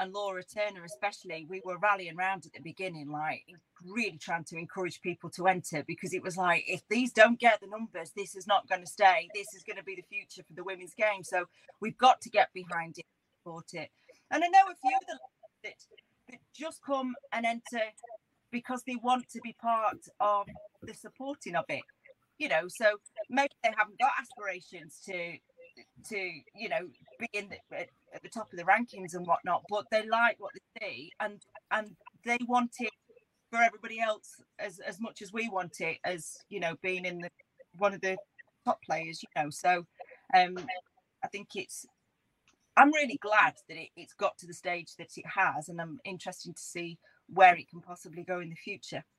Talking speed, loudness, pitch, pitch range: 205 wpm, -31 LUFS, 200 Hz, 180-230 Hz